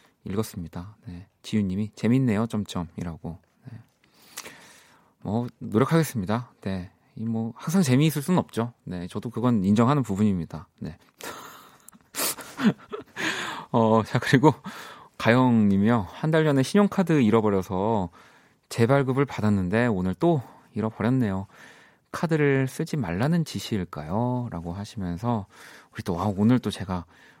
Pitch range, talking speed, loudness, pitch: 100-130 Hz, 270 characters per minute, -25 LUFS, 115 Hz